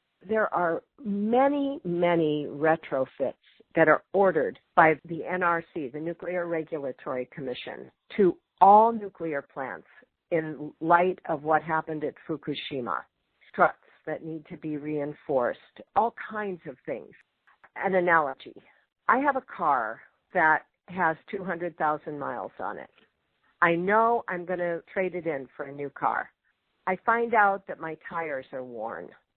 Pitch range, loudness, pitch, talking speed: 155-190 Hz, -27 LUFS, 170 Hz, 140 wpm